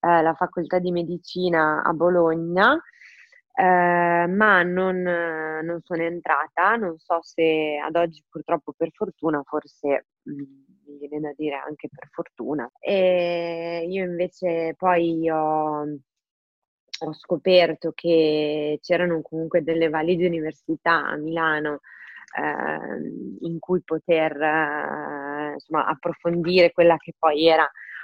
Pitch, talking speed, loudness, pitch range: 165 Hz, 115 wpm, -23 LUFS, 155-175 Hz